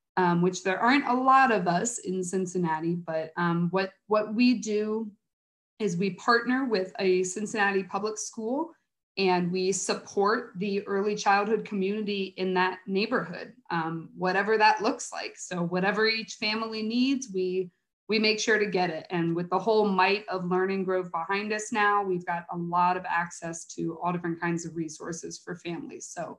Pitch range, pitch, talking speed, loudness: 180-215 Hz, 195 Hz, 175 wpm, -27 LUFS